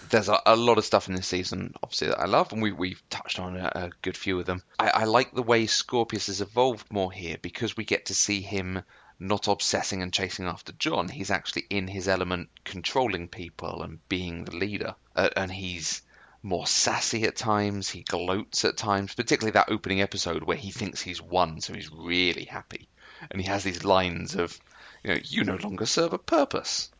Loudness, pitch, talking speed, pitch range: -27 LUFS, 95 Hz, 210 wpm, 90-100 Hz